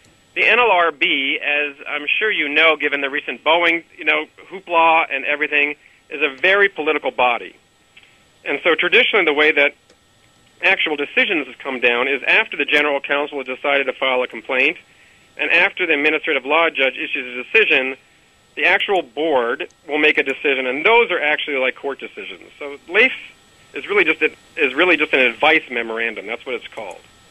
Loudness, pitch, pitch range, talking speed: -16 LUFS, 150 Hz, 140-160 Hz, 180 wpm